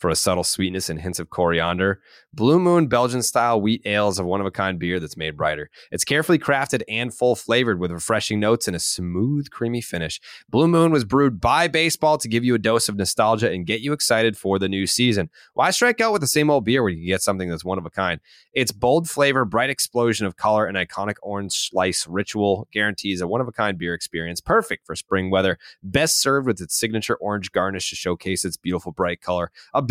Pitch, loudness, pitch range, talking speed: 105 Hz, -21 LUFS, 90-125 Hz, 225 wpm